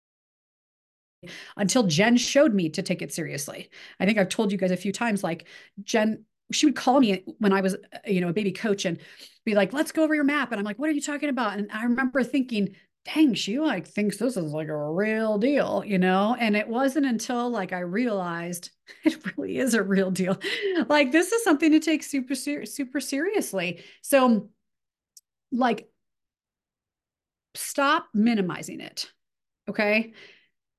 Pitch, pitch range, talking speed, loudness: 220 Hz, 195-280 Hz, 180 wpm, -25 LUFS